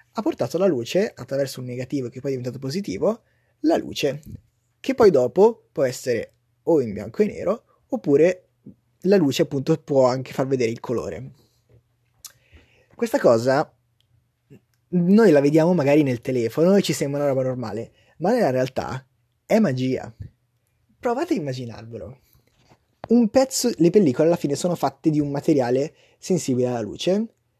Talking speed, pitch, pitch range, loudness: 150 wpm, 135 Hz, 120-170 Hz, -21 LUFS